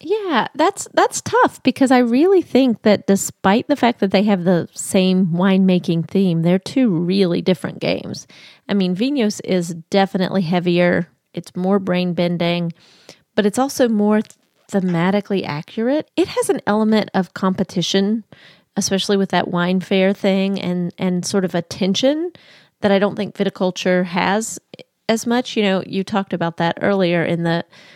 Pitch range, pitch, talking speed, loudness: 180-215 Hz, 195 Hz, 160 wpm, -18 LUFS